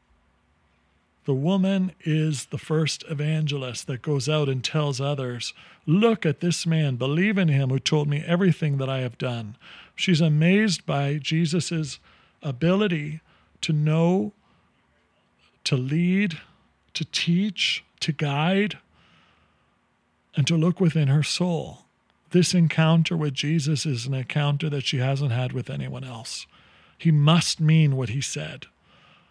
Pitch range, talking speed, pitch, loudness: 135-170 Hz, 135 wpm, 155 Hz, -24 LUFS